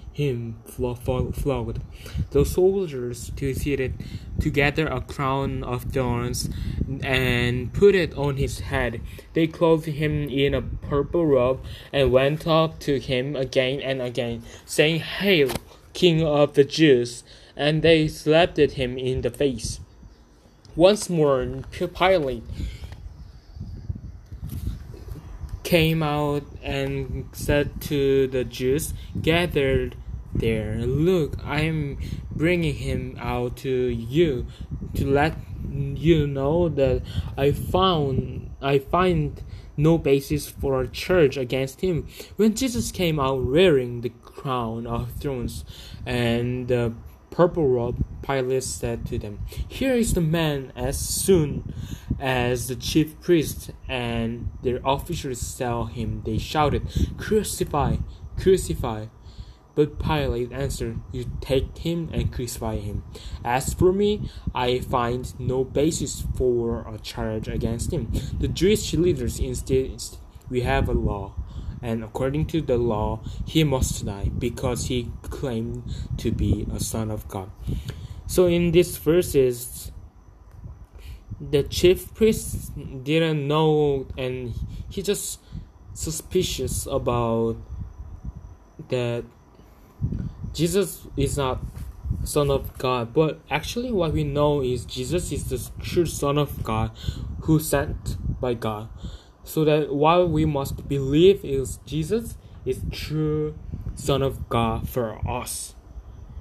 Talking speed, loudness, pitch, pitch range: 120 wpm, -24 LUFS, 130 Hz, 115-150 Hz